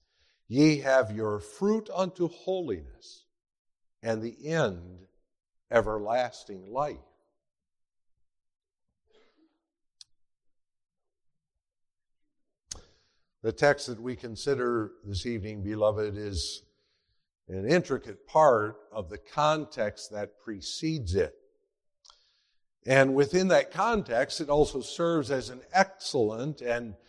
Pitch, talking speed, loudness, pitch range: 130 Hz, 90 wpm, -28 LUFS, 110-175 Hz